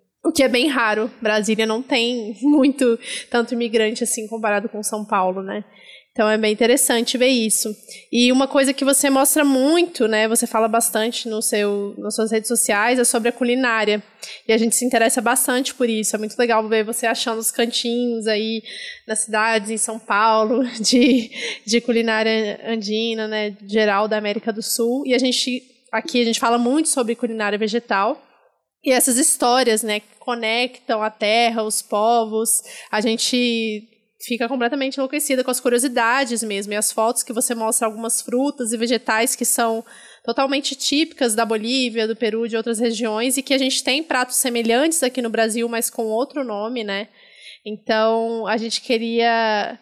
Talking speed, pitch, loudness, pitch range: 175 wpm, 230 Hz, -19 LUFS, 220-250 Hz